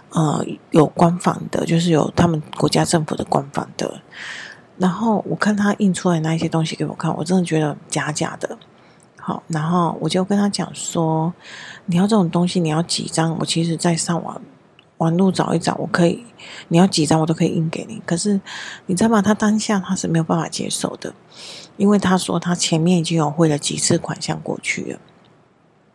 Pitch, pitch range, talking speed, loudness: 175 Hz, 160-190 Hz, 285 characters per minute, -19 LUFS